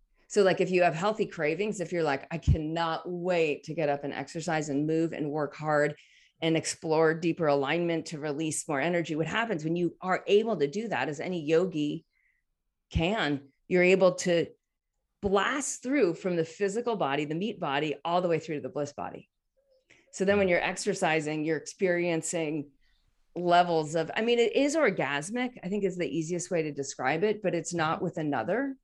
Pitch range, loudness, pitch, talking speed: 155-185 Hz, -29 LUFS, 165 Hz, 190 wpm